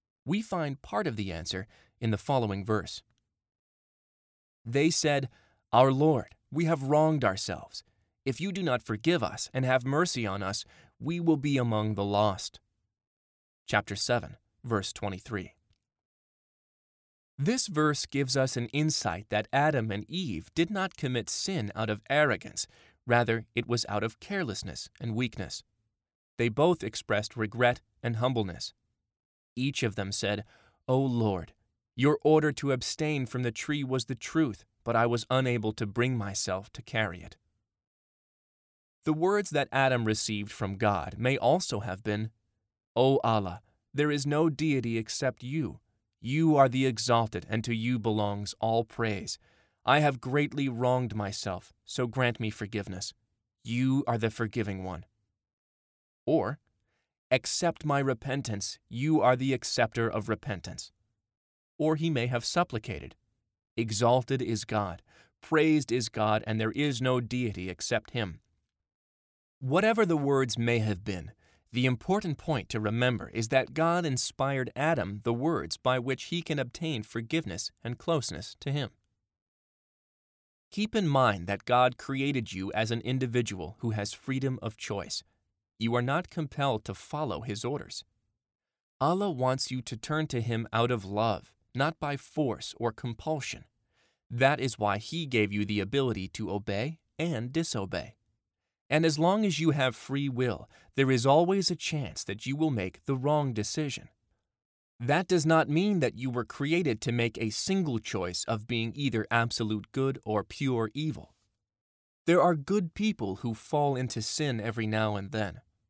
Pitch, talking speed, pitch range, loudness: 120 Hz, 155 wpm, 105-140 Hz, -30 LUFS